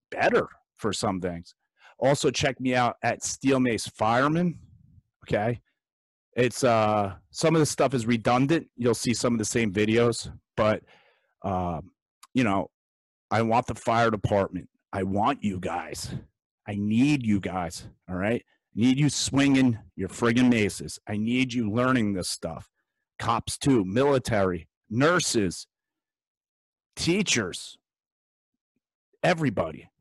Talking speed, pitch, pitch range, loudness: 130 wpm, 115 Hz, 100-130 Hz, -26 LUFS